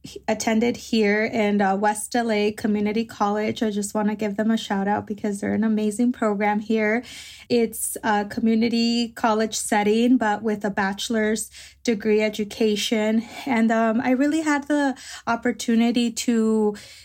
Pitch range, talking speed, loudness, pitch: 210-235 Hz, 150 wpm, -22 LUFS, 220 Hz